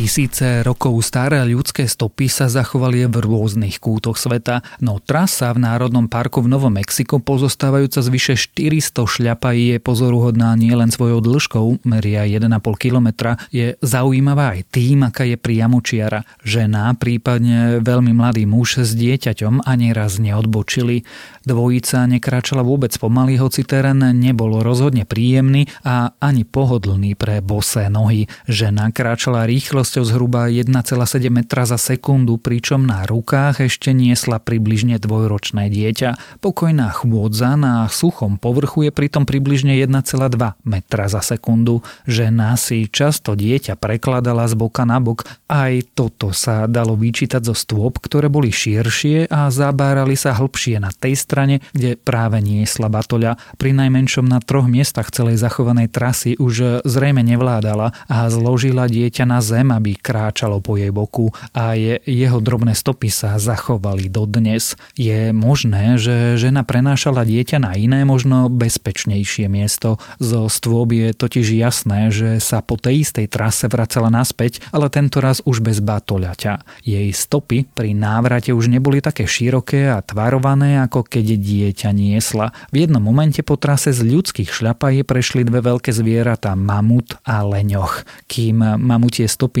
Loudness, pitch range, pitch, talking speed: -16 LUFS, 110-130 Hz, 120 Hz, 145 wpm